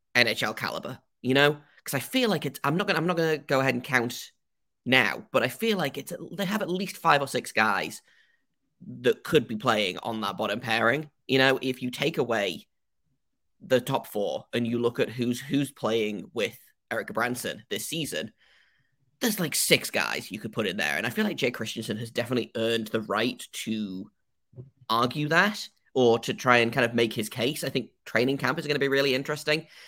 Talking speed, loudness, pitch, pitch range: 210 wpm, -27 LUFS, 130 Hz, 120-150 Hz